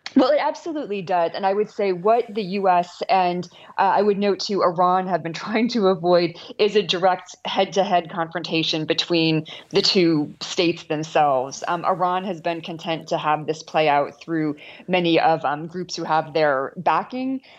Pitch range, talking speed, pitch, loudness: 165-195 Hz, 190 wpm, 180 Hz, -21 LUFS